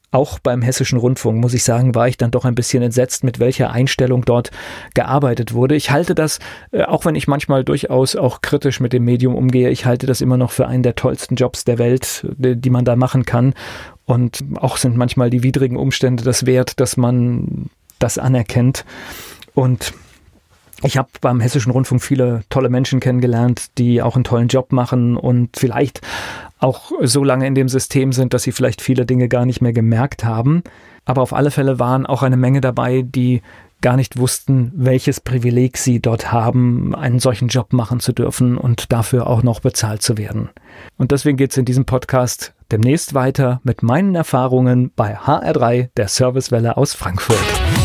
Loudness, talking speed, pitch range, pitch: -16 LUFS, 185 wpm, 120-130 Hz, 125 Hz